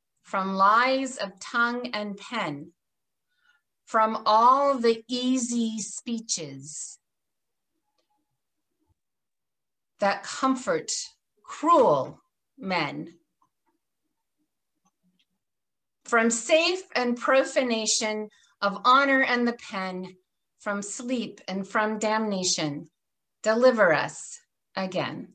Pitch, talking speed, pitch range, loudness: 225 Hz, 75 wpm, 195-265 Hz, -25 LUFS